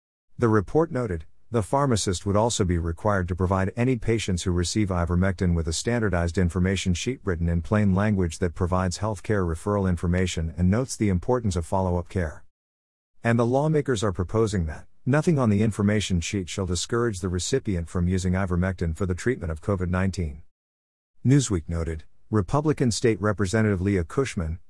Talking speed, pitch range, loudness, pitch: 170 wpm, 90-110 Hz, -25 LUFS, 95 Hz